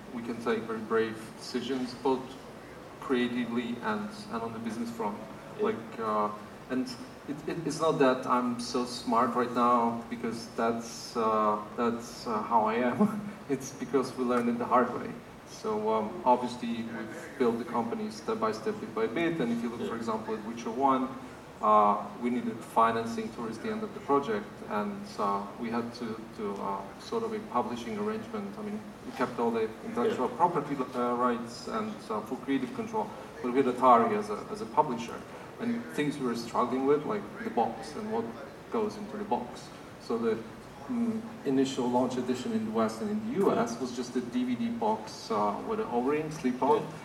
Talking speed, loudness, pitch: 190 wpm, -31 LUFS, 125 Hz